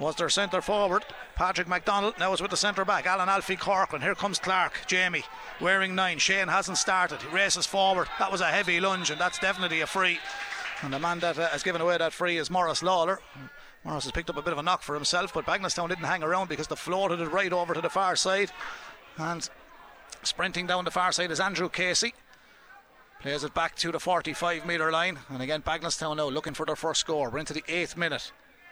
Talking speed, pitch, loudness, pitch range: 225 wpm, 180 Hz, -27 LUFS, 165-190 Hz